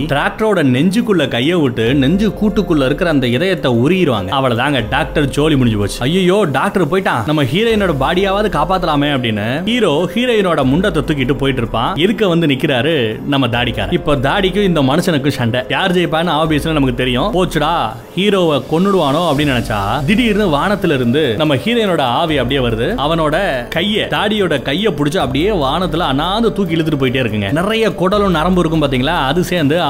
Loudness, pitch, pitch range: -14 LUFS, 155 Hz, 135-190 Hz